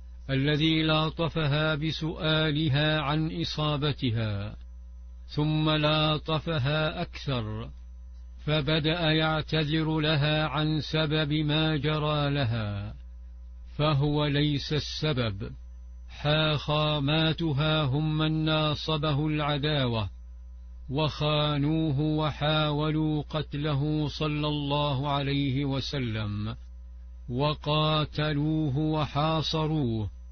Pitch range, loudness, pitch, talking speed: 130-155 Hz, -27 LUFS, 150 Hz, 65 wpm